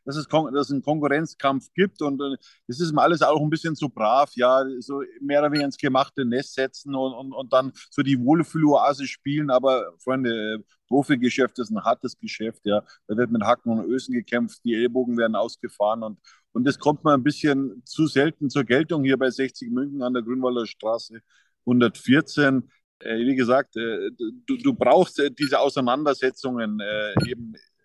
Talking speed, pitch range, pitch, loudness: 185 wpm, 120-145 Hz, 135 Hz, -23 LUFS